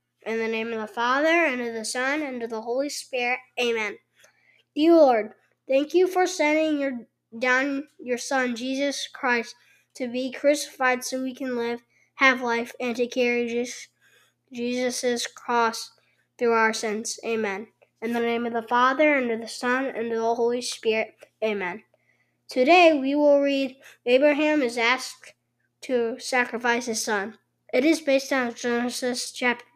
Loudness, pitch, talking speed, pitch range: -24 LUFS, 245 Hz, 160 wpm, 230-270 Hz